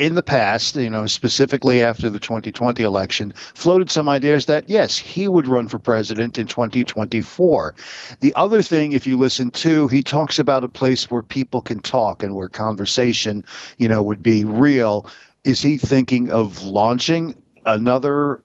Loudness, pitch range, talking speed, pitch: -18 LUFS, 110-145 Hz, 170 wpm, 125 Hz